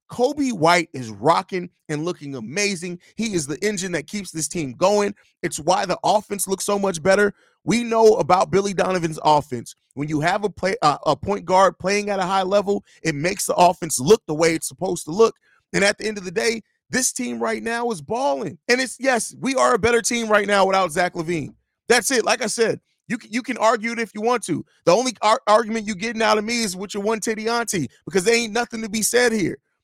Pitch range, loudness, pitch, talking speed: 175-225 Hz, -21 LUFS, 205 Hz, 235 wpm